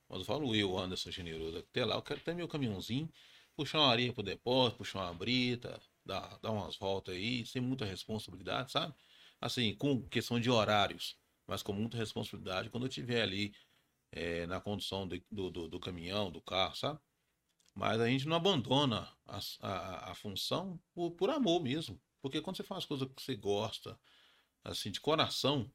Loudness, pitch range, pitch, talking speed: -36 LUFS, 95-135 Hz, 110 Hz, 180 wpm